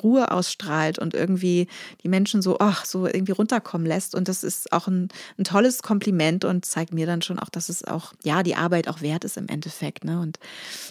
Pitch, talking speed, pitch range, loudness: 180 Hz, 215 wpm, 165-195 Hz, -24 LUFS